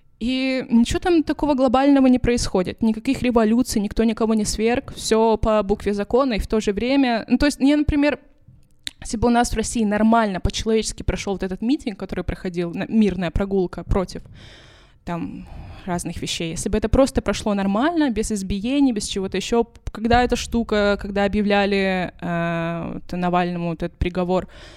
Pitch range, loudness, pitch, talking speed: 195-245 Hz, -21 LUFS, 220 Hz, 170 wpm